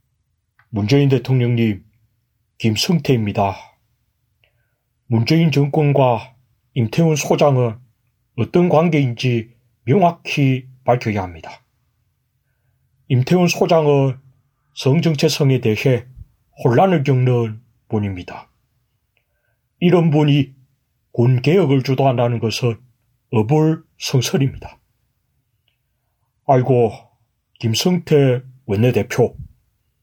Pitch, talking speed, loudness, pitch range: 125 Hz, 190 characters per minute, -17 LUFS, 115-140 Hz